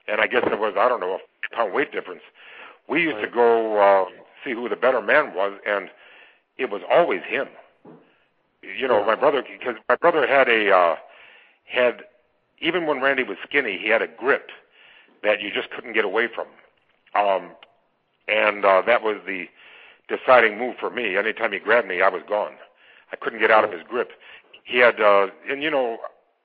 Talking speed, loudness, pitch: 195 wpm, -21 LUFS, 125 Hz